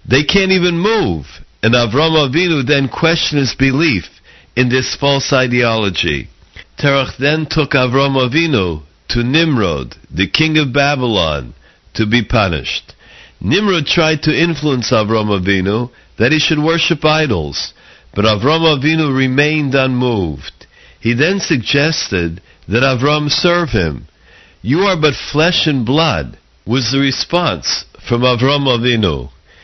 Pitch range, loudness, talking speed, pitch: 110-155 Hz, -14 LUFS, 130 wpm, 135 Hz